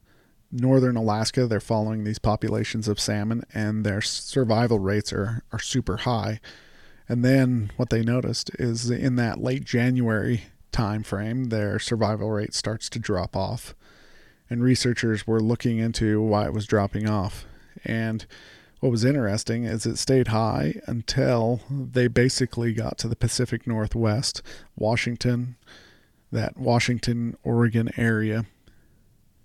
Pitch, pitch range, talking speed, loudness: 115 Hz, 110-120 Hz, 135 wpm, -25 LUFS